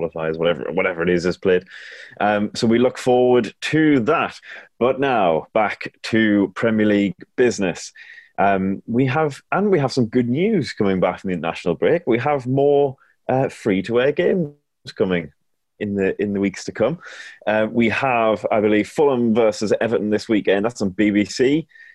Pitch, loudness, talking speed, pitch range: 110 Hz, -19 LUFS, 170 wpm, 100-130 Hz